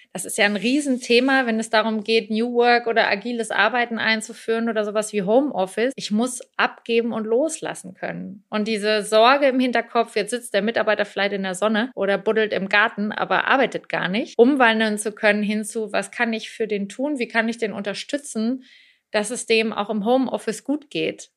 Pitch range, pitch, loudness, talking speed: 210-240 Hz, 225 Hz, -21 LUFS, 195 wpm